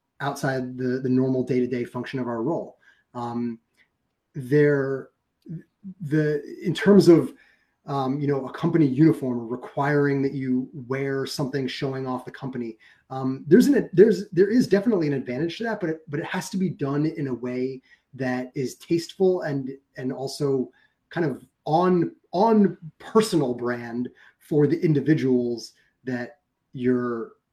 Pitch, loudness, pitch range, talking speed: 135 Hz, -24 LUFS, 125-160 Hz, 155 wpm